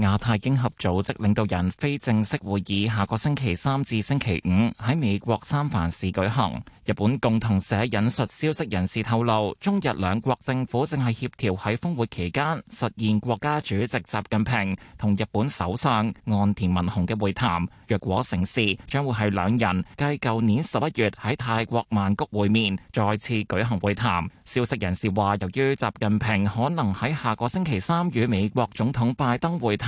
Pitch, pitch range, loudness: 110 Hz, 100-125 Hz, -25 LUFS